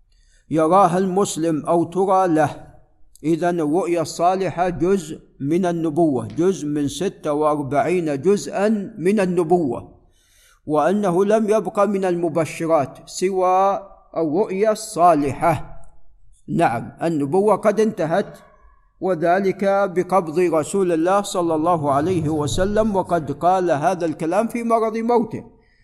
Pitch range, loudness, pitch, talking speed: 155-195 Hz, -20 LUFS, 175 Hz, 105 wpm